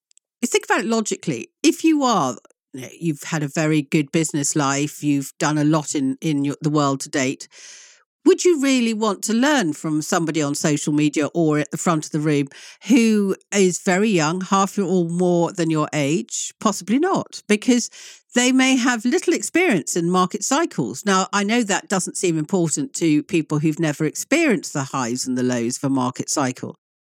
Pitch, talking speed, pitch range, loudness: 170 Hz, 195 wpm, 150-220 Hz, -20 LUFS